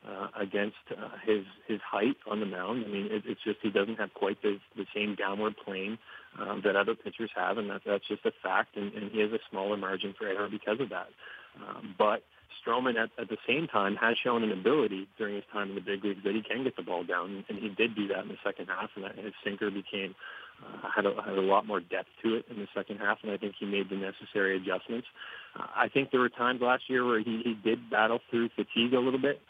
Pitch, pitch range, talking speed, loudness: 105 Hz, 100-115 Hz, 255 wpm, -32 LUFS